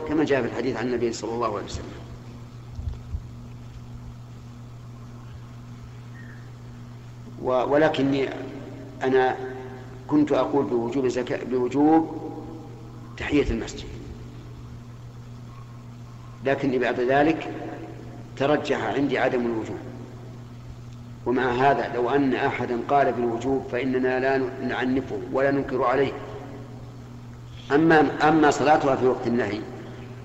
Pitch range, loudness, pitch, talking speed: 120-135 Hz, -24 LUFS, 125 Hz, 90 wpm